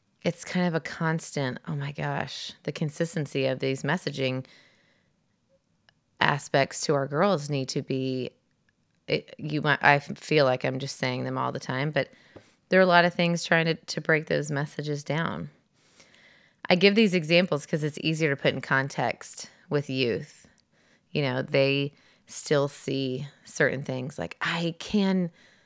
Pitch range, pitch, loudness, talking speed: 135-170 Hz, 150 Hz, -27 LUFS, 165 wpm